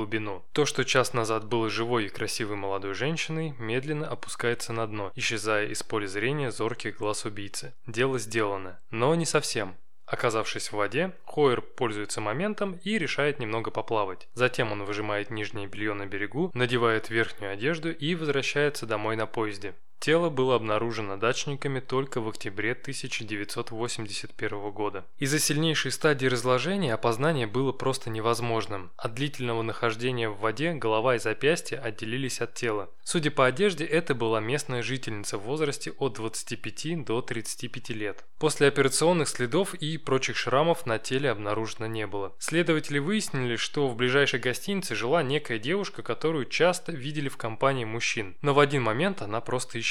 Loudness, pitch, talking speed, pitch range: -28 LUFS, 125 Hz, 155 wpm, 110-145 Hz